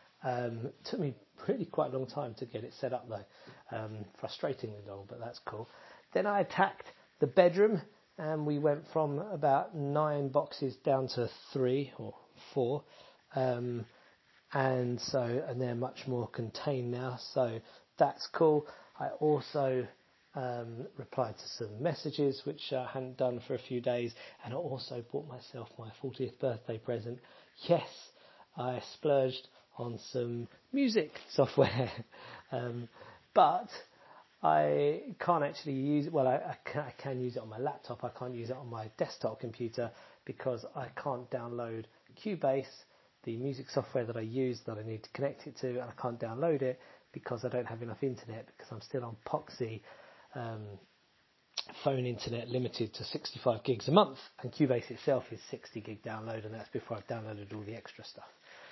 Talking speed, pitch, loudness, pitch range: 170 wpm, 125 Hz, -35 LUFS, 115-140 Hz